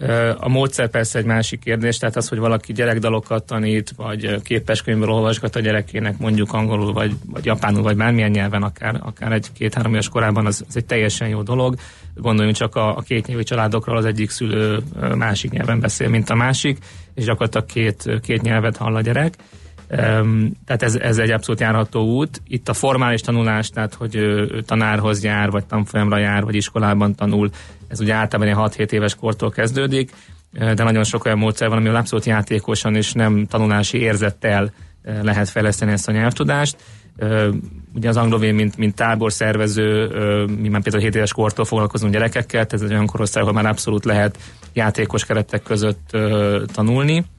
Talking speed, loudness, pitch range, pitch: 170 wpm, -19 LUFS, 105-115 Hz, 110 Hz